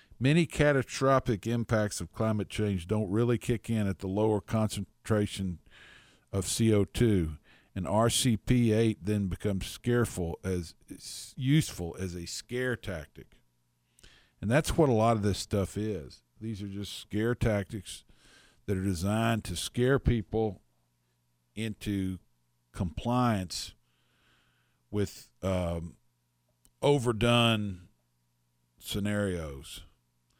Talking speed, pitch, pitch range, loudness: 105 wpm, 100 Hz, 85-115 Hz, -30 LUFS